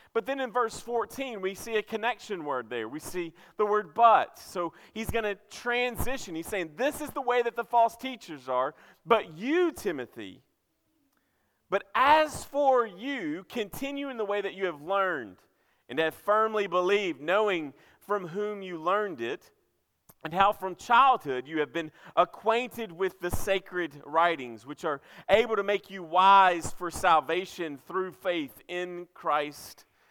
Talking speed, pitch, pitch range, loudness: 165 wpm, 200 Hz, 175-235 Hz, -28 LUFS